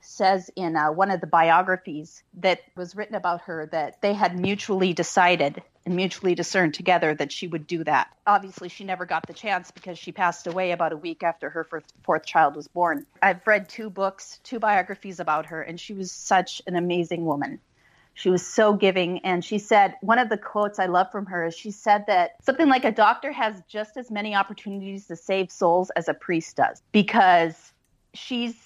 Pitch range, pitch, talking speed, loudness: 170-205 Hz, 185 Hz, 205 wpm, -24 LUFS